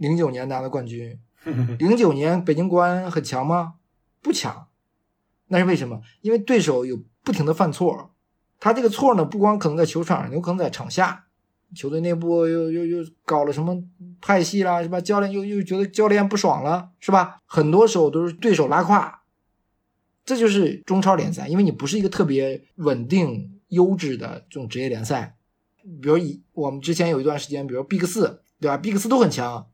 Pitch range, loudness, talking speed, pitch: 145-195 Hz, -21 LUFS, 295 characters per minute, 170 Hz